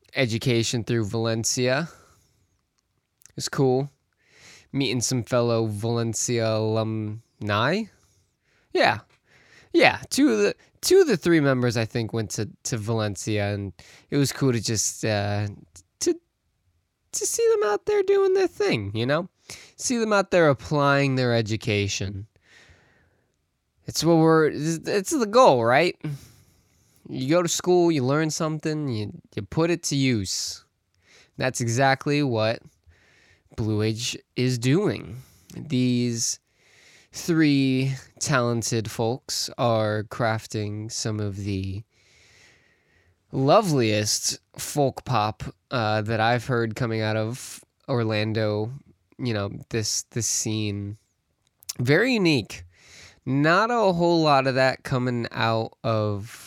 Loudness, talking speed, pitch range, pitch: -24 LUFS, 120 wpm, 110-145 Hz, 120 Hz